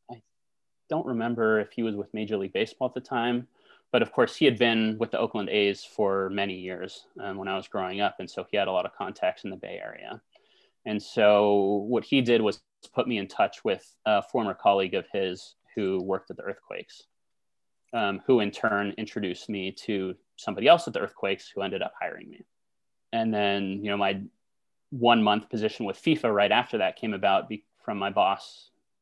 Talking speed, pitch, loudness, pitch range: 205 wpm, 105 Hz, -27 LUFS, 95-115 Hz